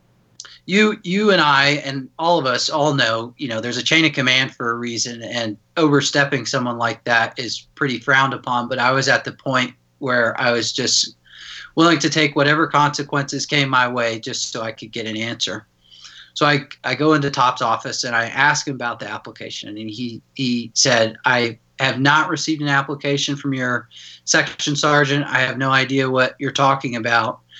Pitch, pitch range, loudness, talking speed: 130 Hz, 120-145 Hz, -18 LUFS, 195 wpm